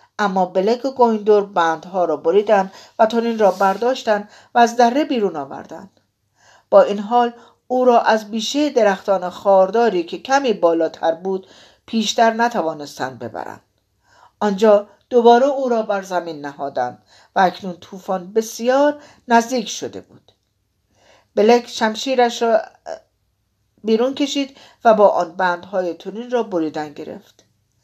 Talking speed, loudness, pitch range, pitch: 125 wpm, -18 LUFS, 185-240 Hz, 215 Hz